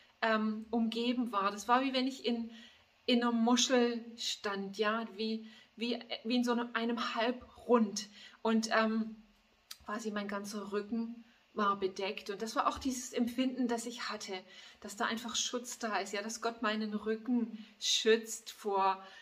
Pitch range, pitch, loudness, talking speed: 210-240 Hz, 225 Hz, -34 LUFS, 160 wpm